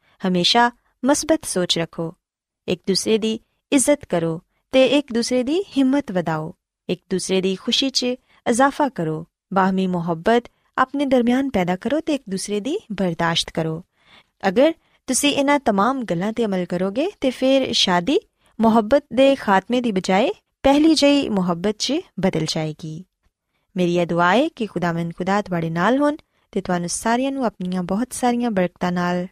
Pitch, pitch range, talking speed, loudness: 215 Hz, 180-265 Hz, 150 wpm, -20 LUFS